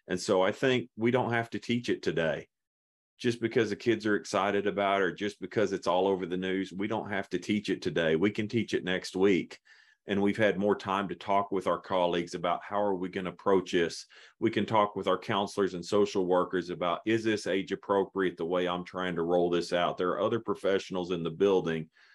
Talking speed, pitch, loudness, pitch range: 235 wpm, 95 Hz, -30 LUFS, 90-105 Hz